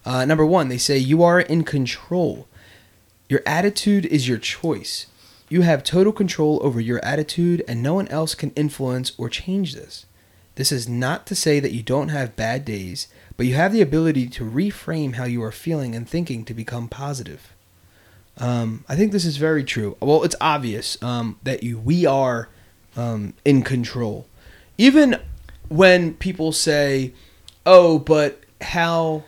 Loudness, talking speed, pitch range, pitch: -20 LUFS, 170 wpm, 115-160 Hz, 135 Hz